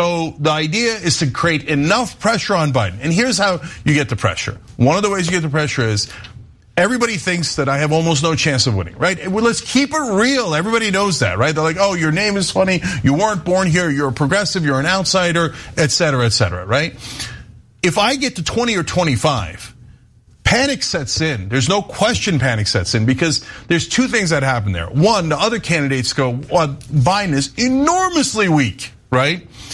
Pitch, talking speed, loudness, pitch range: 160 Hz, 200 wpm, -16 LUFS, 130-190 Hz